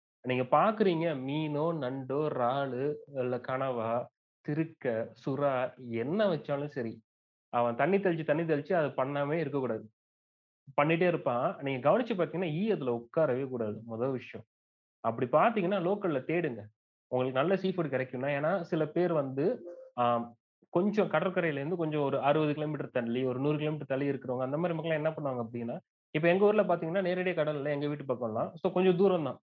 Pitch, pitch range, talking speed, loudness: 145 Hz, 125-170 Hz, 150 wpm, -31 LUFS